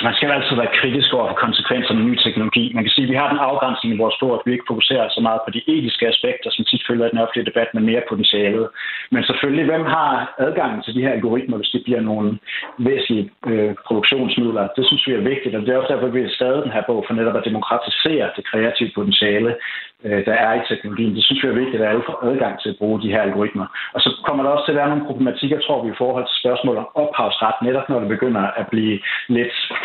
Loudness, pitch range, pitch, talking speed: -18 LUFS, 110-130 Hz, 120 Hz, 255 wpm